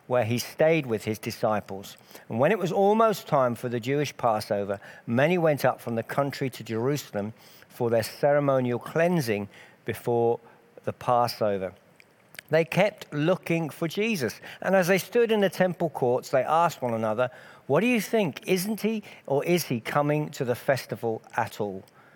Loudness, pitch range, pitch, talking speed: -26 LUFS, 115-175 Hz, 140 Hz, 170 wpm